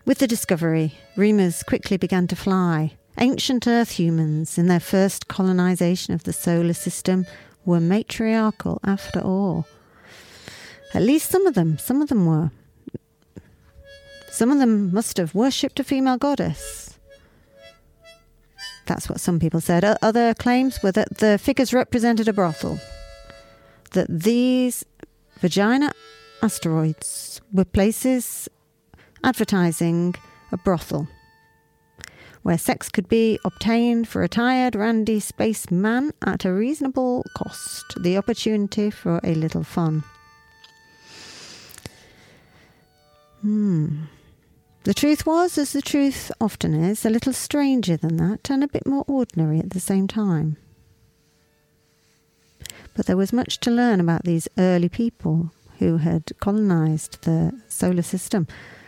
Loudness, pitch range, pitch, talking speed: -22 LUFS, 160-230 Hz, 190 Hz, 125 wpm